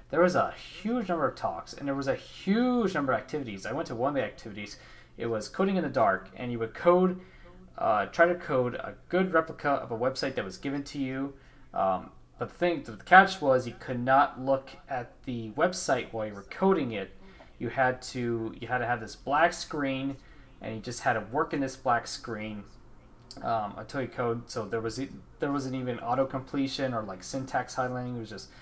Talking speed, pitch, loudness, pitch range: 220 wpm, 130 Hz, -29 LUFS, 115-150 Hz